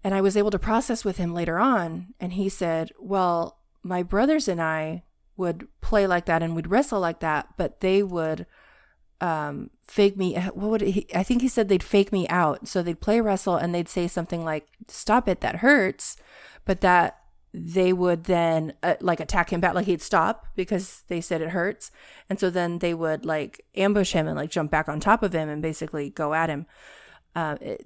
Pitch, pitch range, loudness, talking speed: 180 Hz, 165-200 Hz, -24 LUFS, 210 wpm